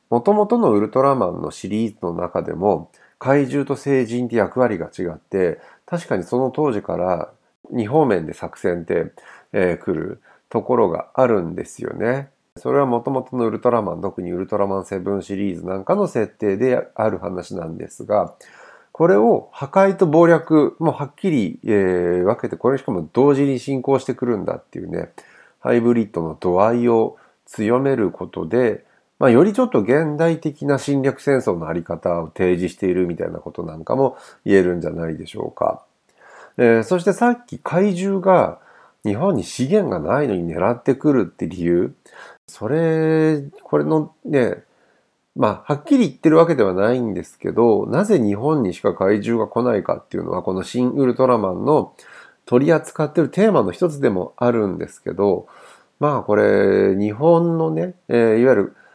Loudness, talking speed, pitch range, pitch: -19 LUFS, 335 characters per minute, 100-155 Hz, 125 Hz